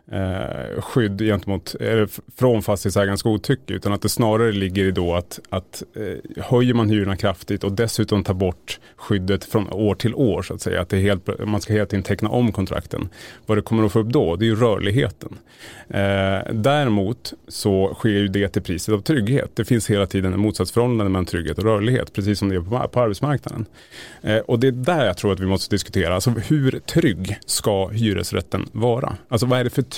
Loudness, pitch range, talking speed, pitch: -21 LUFS, 95-115 Hz, 200 wpm, 105 Hz